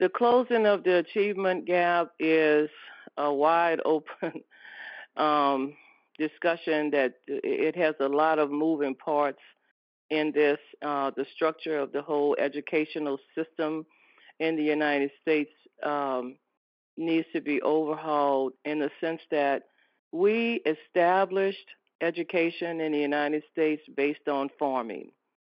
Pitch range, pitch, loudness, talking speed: 145-165 Hz, 155 Hz, -27 LUFS, 125 wpm